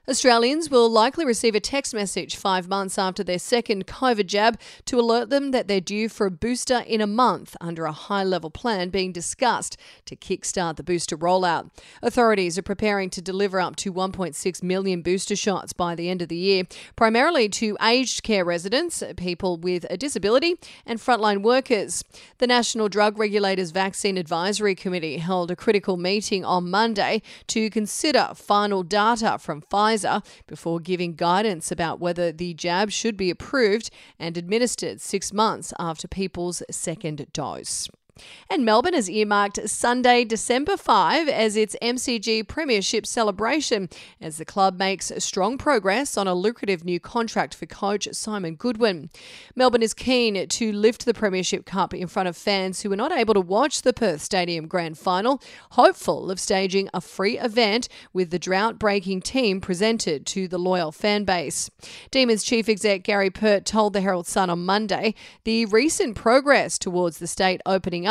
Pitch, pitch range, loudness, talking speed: 200 Hz, 185-225 Hz, -23 LUFS, 165 wpm